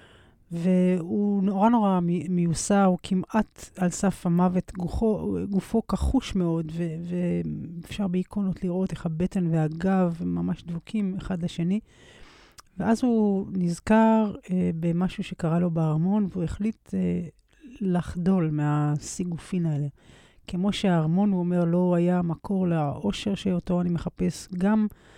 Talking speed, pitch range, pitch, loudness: 120 wpm, 170-195 Hz, 180 Hz, -26 LUFS